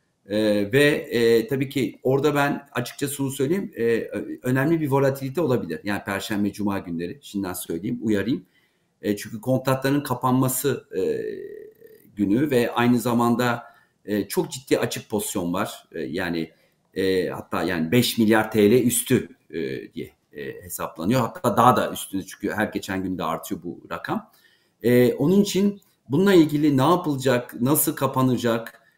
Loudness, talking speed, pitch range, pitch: -23 LUFS, 145 wpm, 105-145 Hz, 125 Hz